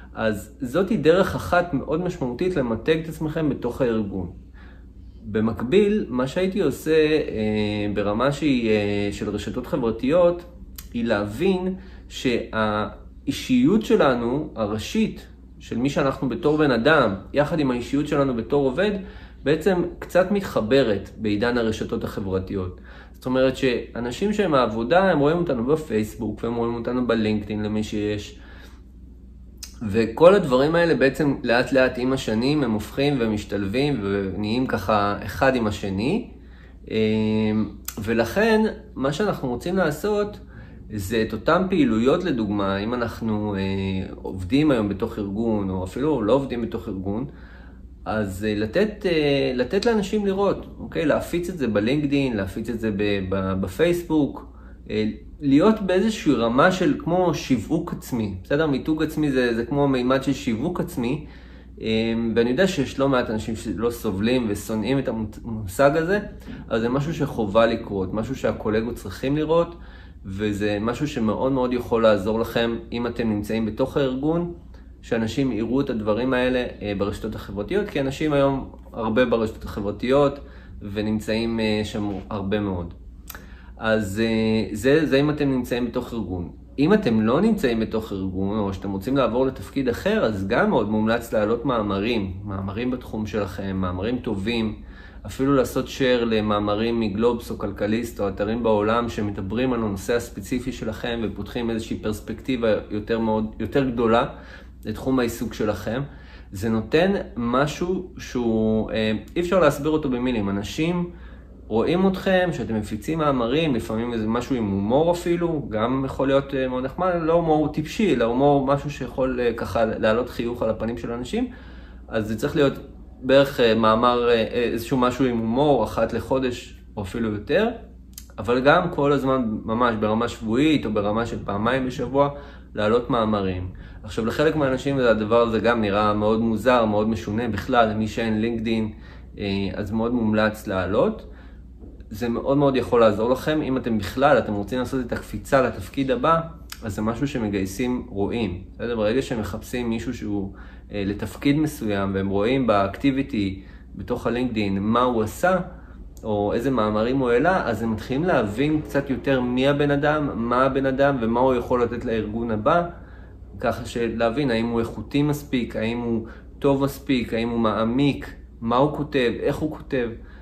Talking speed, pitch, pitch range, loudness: 140 wpm, 115 Hz, 105-135 Hz, -23 LUFS